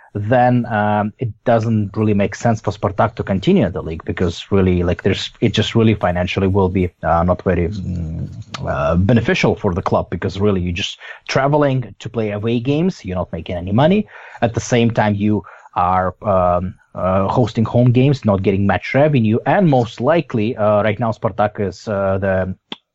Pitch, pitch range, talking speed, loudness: 105 Hz, 95-120 Hz, 185 wpm, -17 LUFS